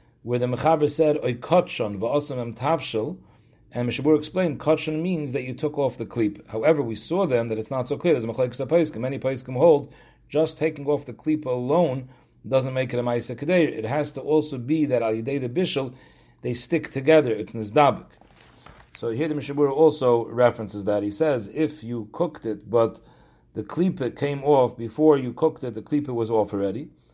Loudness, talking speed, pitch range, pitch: -24 LUFS, 180 wpm, 115-155 Hz, 135 Hz